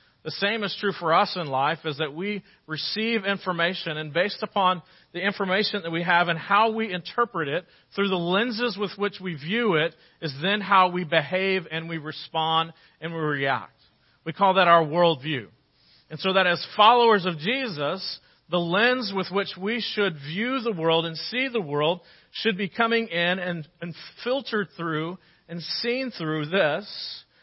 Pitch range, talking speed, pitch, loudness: 165-205 Hz, 180 wpm, 180 Hz, -24 LUFS